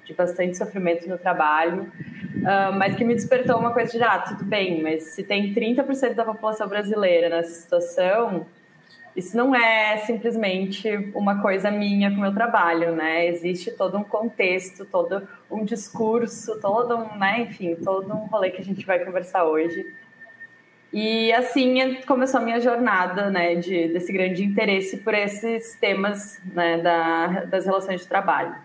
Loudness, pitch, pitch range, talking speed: -23 LUFS, 200 Hz, 180-230 Hz, 155 wpm